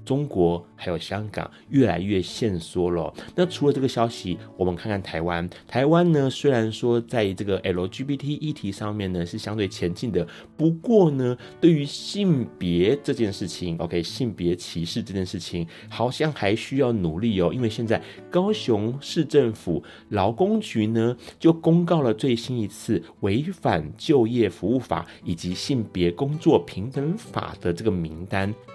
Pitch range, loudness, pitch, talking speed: 90-135 Hz, -24 LUFS, 110 Hz, 255 characters per minute